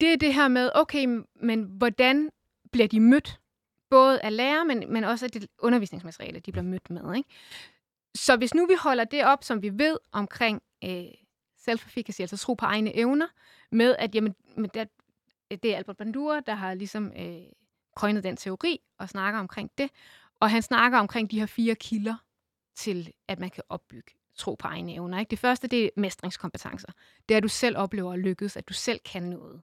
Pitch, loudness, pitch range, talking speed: 225 Hz, -26 LUFS, 200-250 Hz, 195 wpm